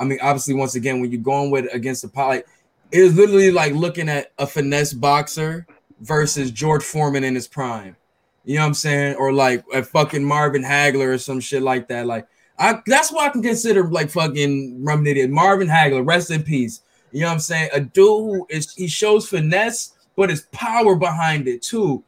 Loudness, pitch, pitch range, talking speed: -18 LUFS, 145 Hz, 135-175 Hz, 205 wpm